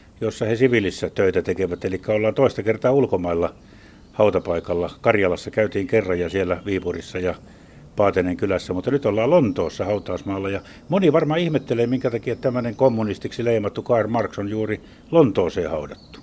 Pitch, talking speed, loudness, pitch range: 105 Hz, 150 wpm, -22 LUFS, 90-120 Hz